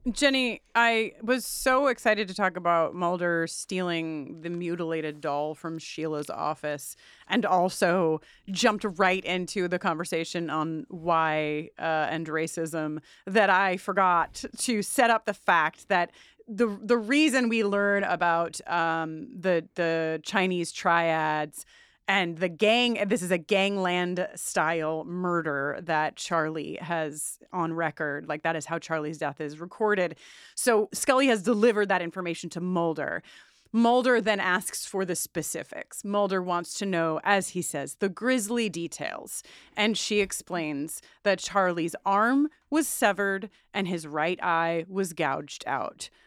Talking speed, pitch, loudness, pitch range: 140 wpm, 180 Hz, -27 LUFS, 165-210 Hz